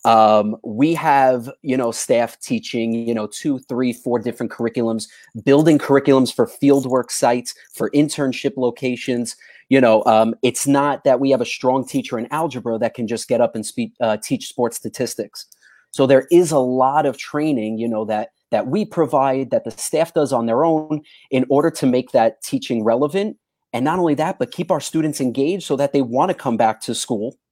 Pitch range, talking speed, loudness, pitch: 115-150 Hz, 200 wpm, -19 LUFS, 130 Hz